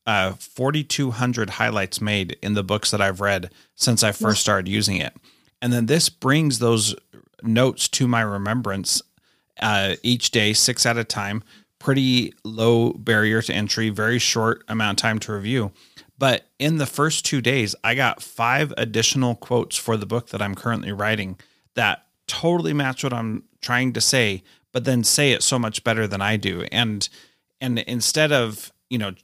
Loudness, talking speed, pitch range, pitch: -21 LUFS, 175 wpm, 105-125 Hz, 115 Hz